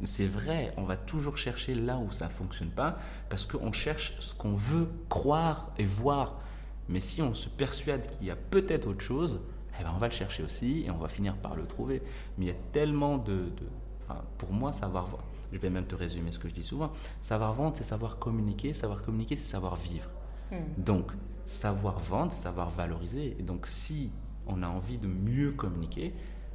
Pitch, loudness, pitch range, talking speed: 105 Hz, -34 LUFS, 90-140 Hz, 210 wpm